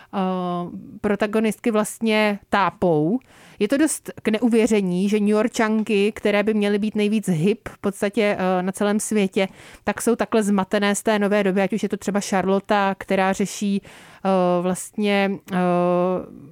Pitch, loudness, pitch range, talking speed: 205 Hz, -21 LUFS, 190-215 Hz, 140 wpm